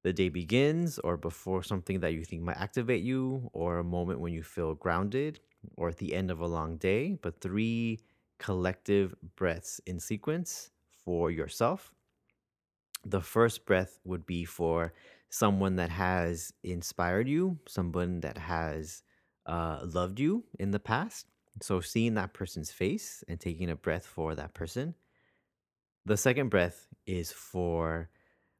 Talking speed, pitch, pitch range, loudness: 150 wpm, 90 Hz, 85-105 Hz, -33 LUFS